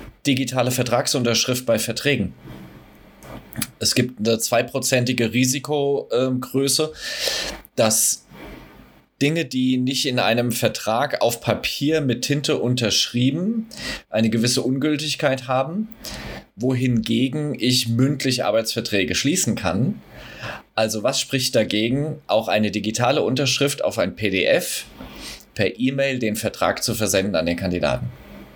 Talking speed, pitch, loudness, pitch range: 105 wpm, 125 Hz, -21 LUFS, 115-140 Hz